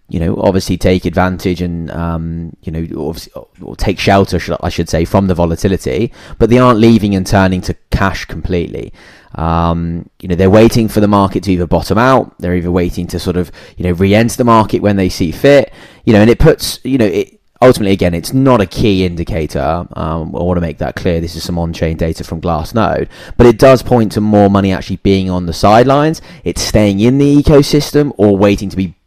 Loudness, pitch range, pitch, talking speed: -12 LUFS, 85-110 Hz, 95 Hz, 215 wpm